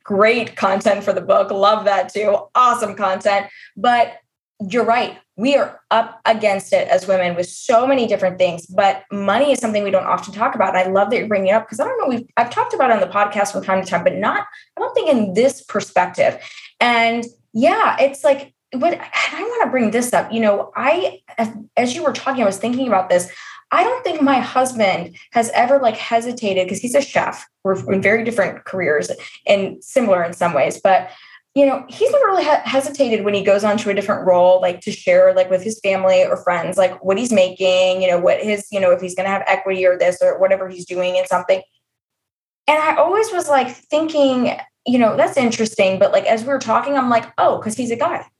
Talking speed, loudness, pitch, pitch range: 225 wpm, -17 LUFS, 220 Hz, 195-270 Hz